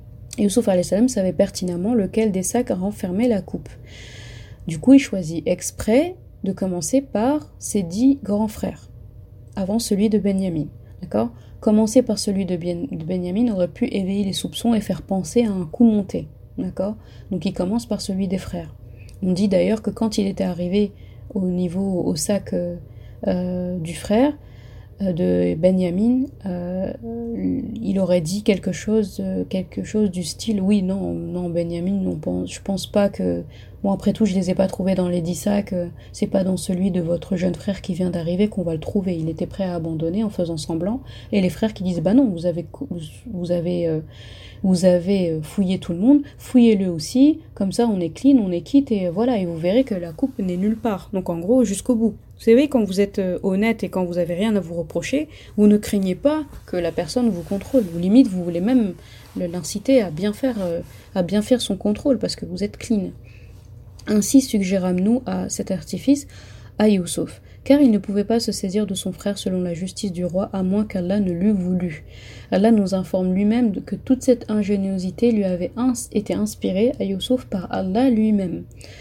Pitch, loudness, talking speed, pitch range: 195 Hz, -21 LUFS, 195 wpm, 175-215 Hz